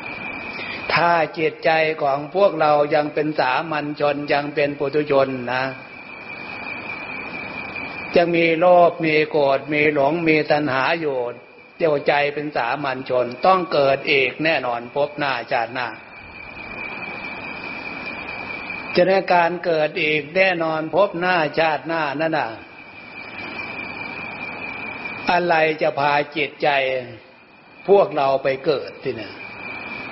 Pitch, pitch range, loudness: 150 Hz, 140-165 Hz, -20 LUFS